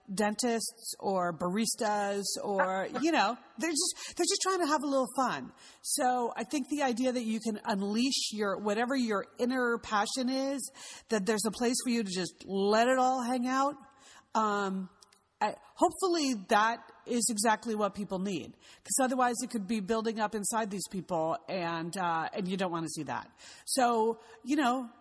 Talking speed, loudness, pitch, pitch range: 180 wpm, -31 LUFS, 230 Hz, 205-255 Hz